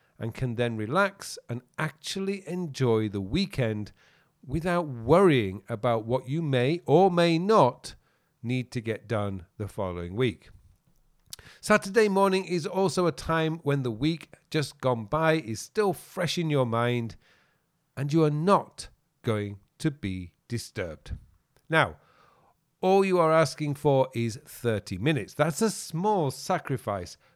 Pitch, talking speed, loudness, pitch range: 140 Hz, 140 wpm, -27 LUFS, 115-170 Hz